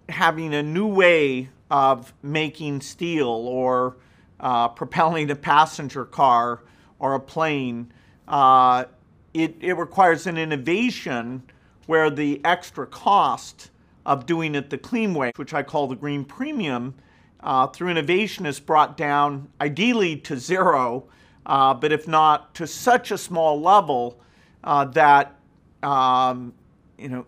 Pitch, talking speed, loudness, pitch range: 145 Hz, 135 wpm, -21 LUFS, 130-160 Hz